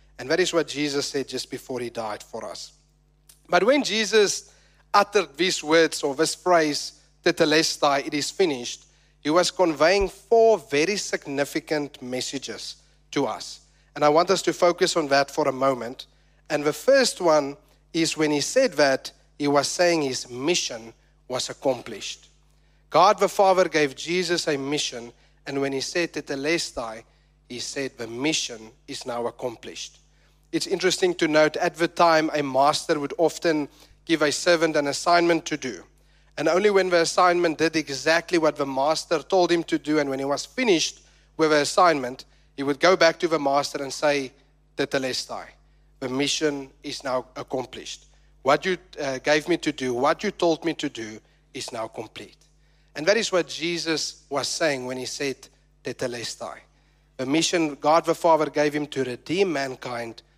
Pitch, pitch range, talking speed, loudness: 150 Hz, 140-170 Hz, 170 wpm, -23 LUFS